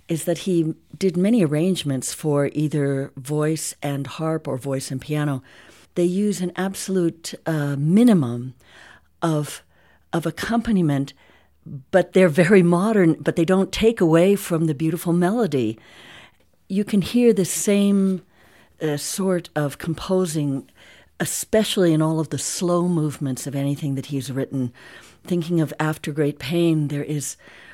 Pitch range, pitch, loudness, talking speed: 145-185 Hz, 160 Hz, -21 LUFS, 140 wpm